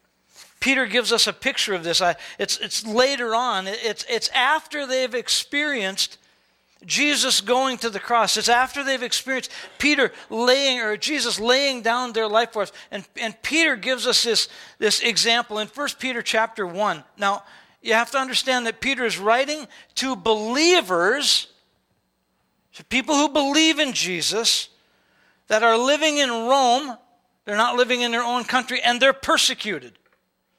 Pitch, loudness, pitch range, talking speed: 240 Hz, -20 LUFS, 220-265 Hz, 155 wpm